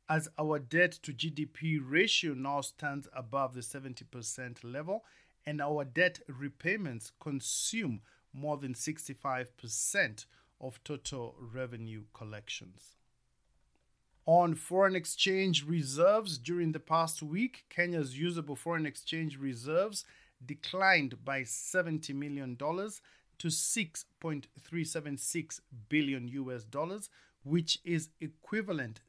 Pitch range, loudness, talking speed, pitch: 130-165 Hz, -34 LUFS, 105 wpm, 150 Hz